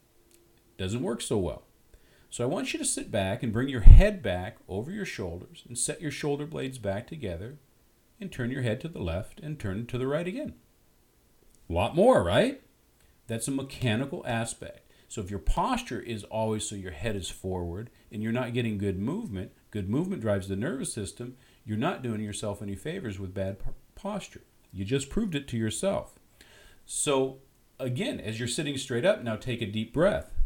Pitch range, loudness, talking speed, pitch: 105-130 Hz, -30 LUFS, 190 wpm, 115 Hz